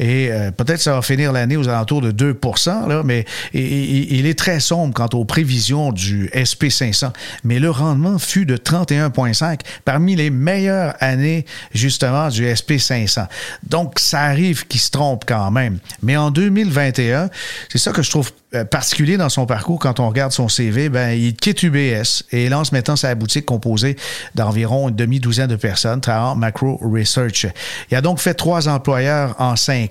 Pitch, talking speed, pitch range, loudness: 135 Hz, 170 wpm, 120-150 Hz, -17 LUFS